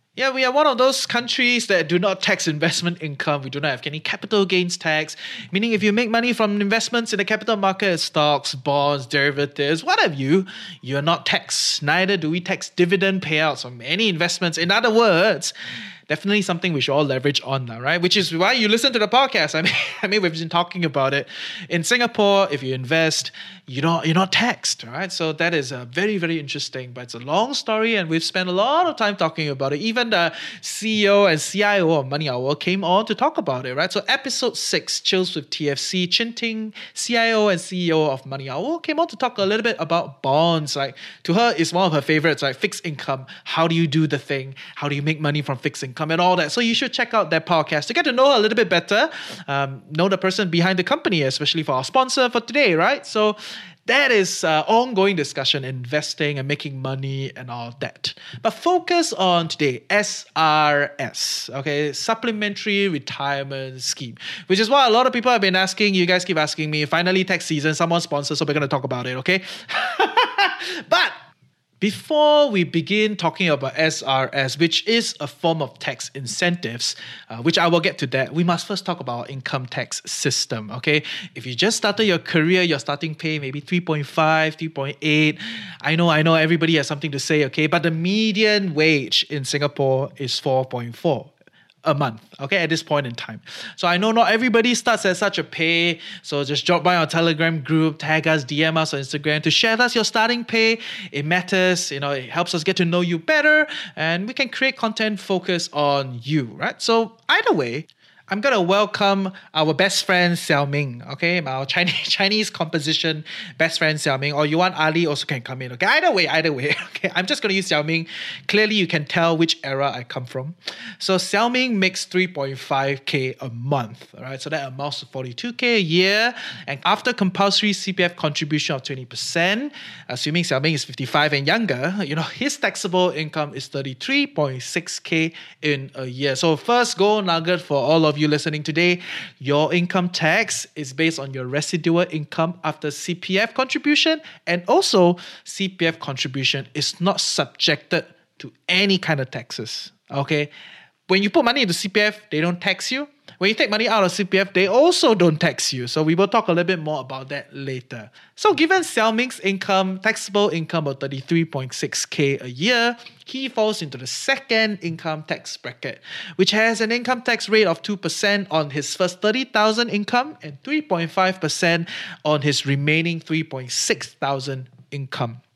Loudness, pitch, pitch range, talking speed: -20 LUFS, 170 Hz, 145-205 Hz, 195 wpm